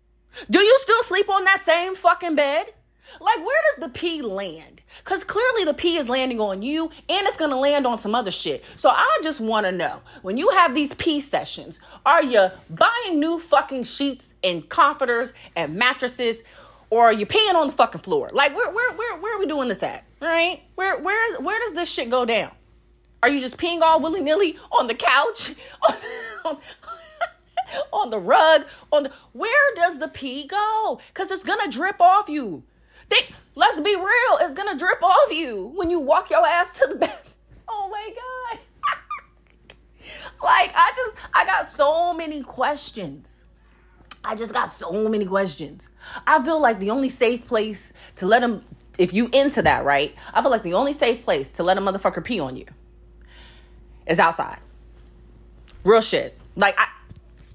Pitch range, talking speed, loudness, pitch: 230-380 Hz, 185 wpm, -21 LUFS, 310 Hz